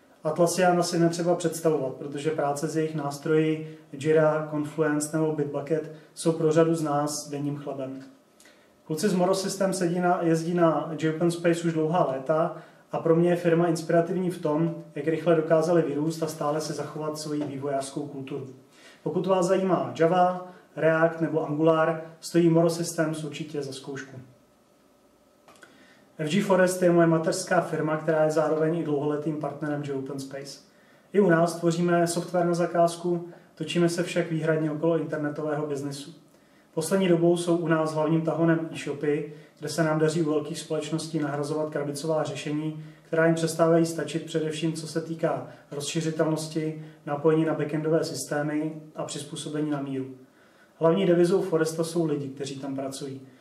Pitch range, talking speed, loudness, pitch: 150-165 Hz, 155 wpm, -26 LUFS, 160 Hz